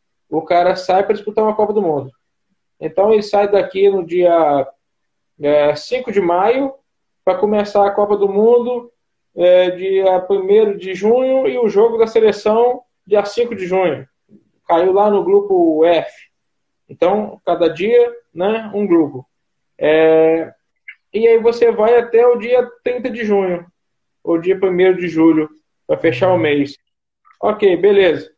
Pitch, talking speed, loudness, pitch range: 200 Hz, 145 wpm, -15 LUFS, 175-240 Hz